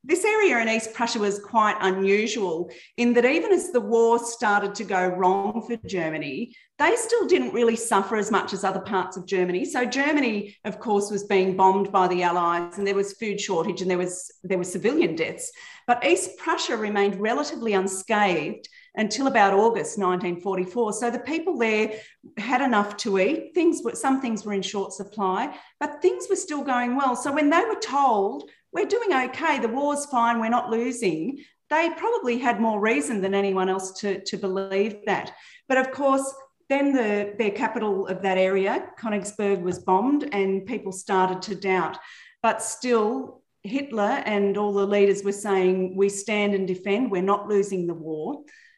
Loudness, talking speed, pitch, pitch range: -24 LUFS, 180 wpm, 215 Hz, 195-265 Hz